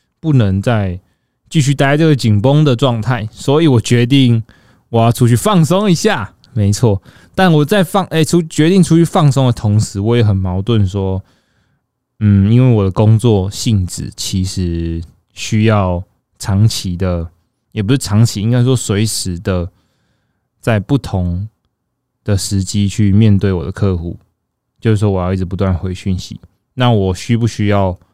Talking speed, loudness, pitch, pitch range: 230 characters per minute, -14 LUFS, 110 Hz, 95-125 Hz